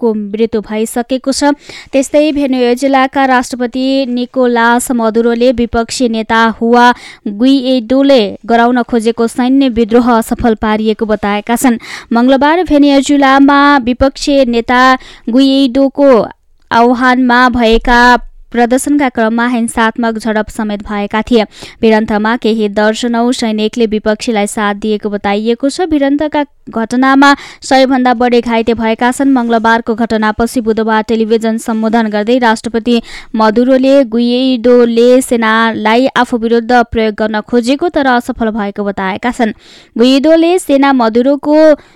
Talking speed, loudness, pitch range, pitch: 105 wpm, -10 LUFS, 225-265 Hz, 240 Hz